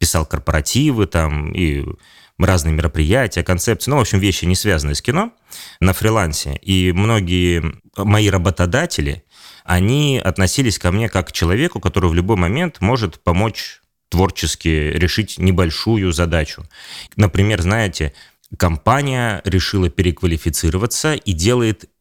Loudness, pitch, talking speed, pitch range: -17 LUFS, 95 Hz, 125 wpm, 85-105 Hz